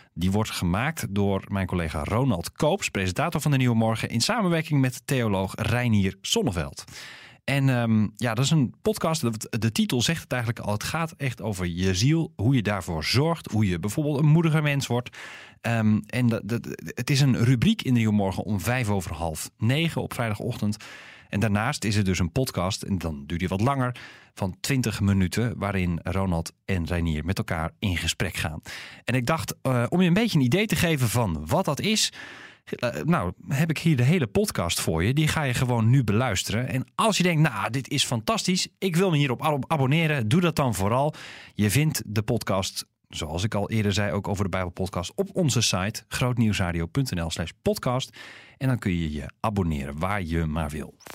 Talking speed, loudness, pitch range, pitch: 200 wpm, -25 LUFS, 95-140 Hz, 115 Hz